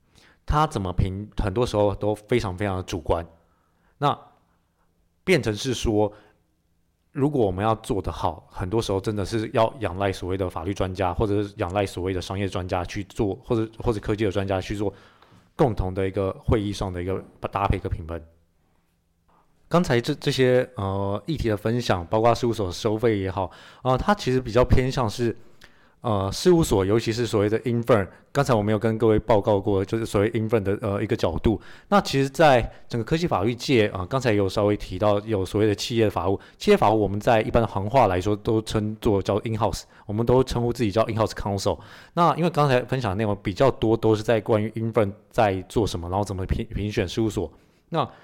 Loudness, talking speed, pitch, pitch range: -24 LUFS, 340 characters per minute, 105 Hz, 95-115 Hz